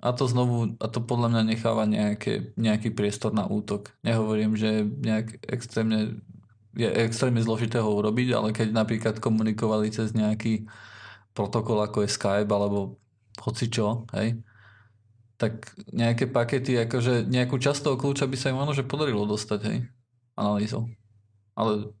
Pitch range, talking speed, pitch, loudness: 105-120 Hz, 145 wpm, 110 Hz, -26 LUFS